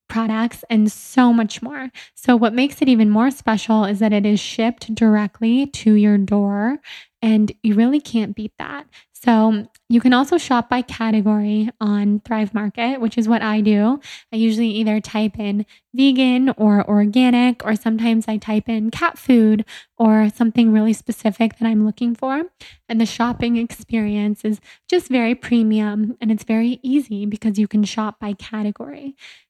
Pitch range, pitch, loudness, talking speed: 215-240 Hz, 225 Hz, -18 LUFS, 170 wpm